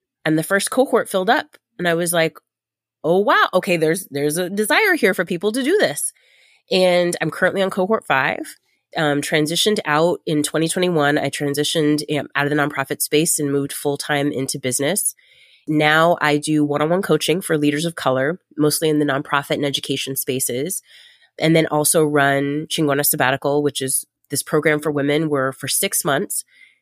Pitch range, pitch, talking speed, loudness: 145-175 Hz, 150 Hz, 180 wpm, -19 LUFS